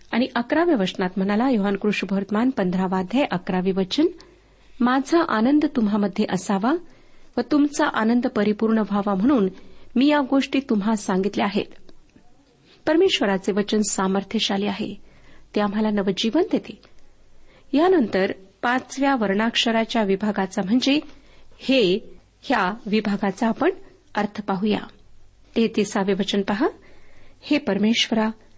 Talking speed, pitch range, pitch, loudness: 105 wpm, 200-265 Hz, 220 Hz, -22 LUFS